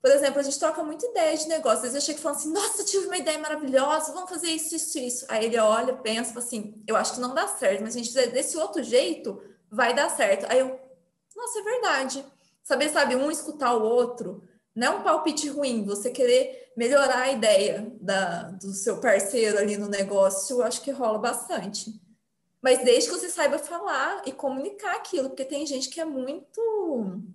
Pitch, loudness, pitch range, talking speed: 270 Hz, -25 LUFS, 225-320 Hz, 205 wpm